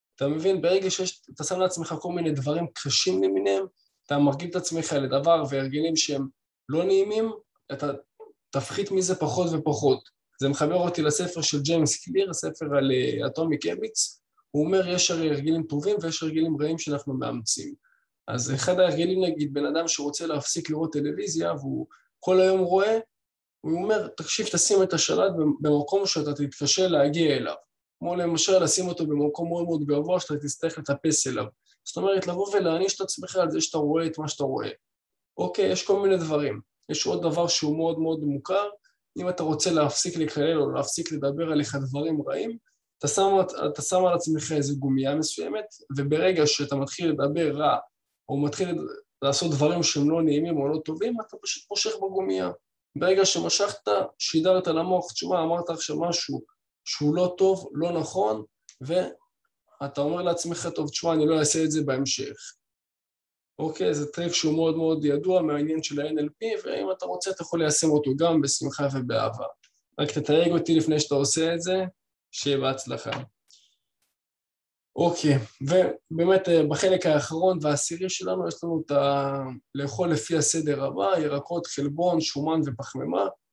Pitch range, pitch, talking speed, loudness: 145-180 Hz, 160 Hz, 160 wpm, -25 LUFS